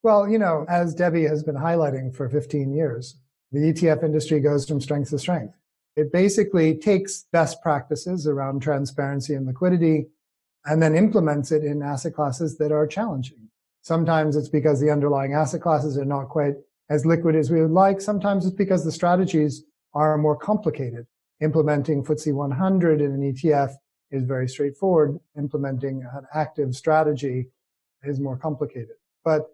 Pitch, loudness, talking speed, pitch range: 150 Hz, -23 LUFS, 160 wpm, 140-165 Hz